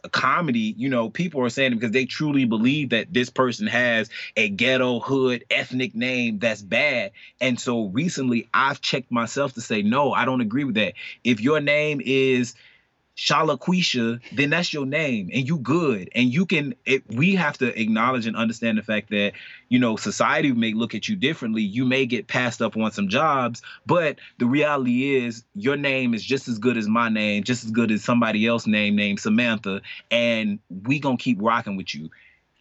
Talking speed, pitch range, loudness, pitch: 195 wpm, 115-140 Hz, -22 LUFS, 125 Hz